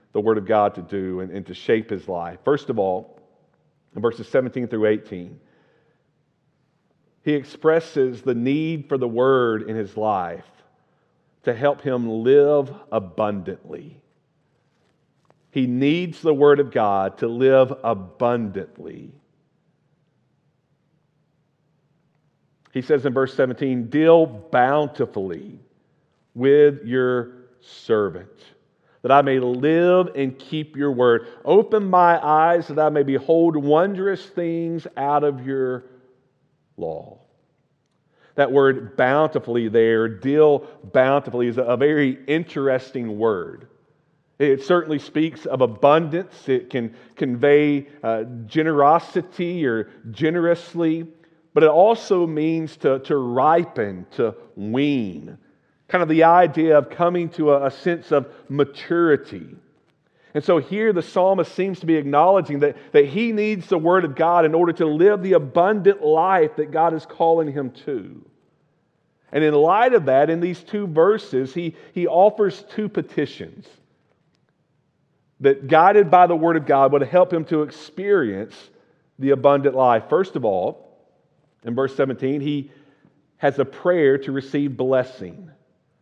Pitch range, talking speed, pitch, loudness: 130-165 Hz, 135 wpm, 145 Hz, -19 LUFS